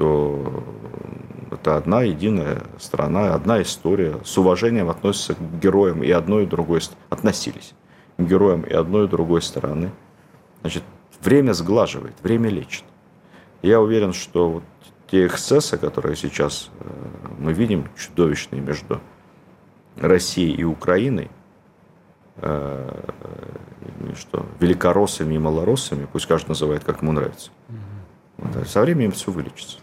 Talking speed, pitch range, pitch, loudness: 115 wpm, 75-100 Hz, 85 Hz, -21 LUFS